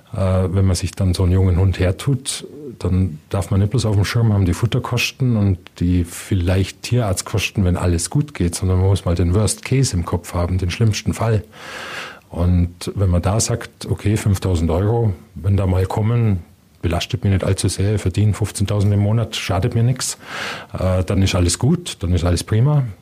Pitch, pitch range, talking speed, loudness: 100 Hz, 90-110 Hz, 195 wpm, -19 LUFS